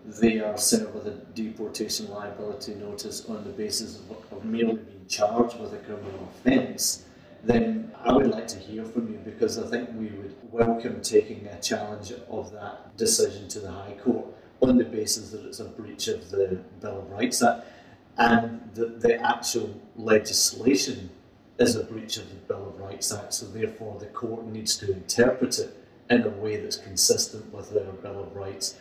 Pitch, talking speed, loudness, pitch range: 115 Hz, 185 wpm, -27 LUFS, 105-130 Hz